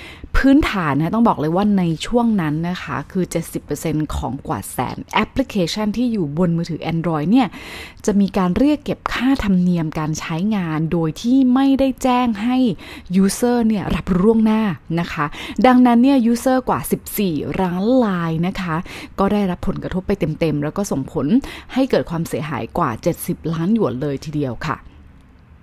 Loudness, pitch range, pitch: -19 LUFS, 160-230 Hz, 185 Hz